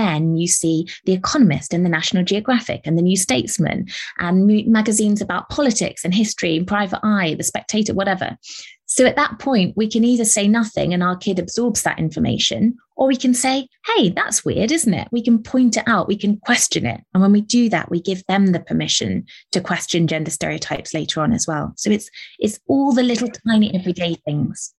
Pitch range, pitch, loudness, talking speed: 175-235 Hz, 205 Hz, -18 LUFS, 205 wpm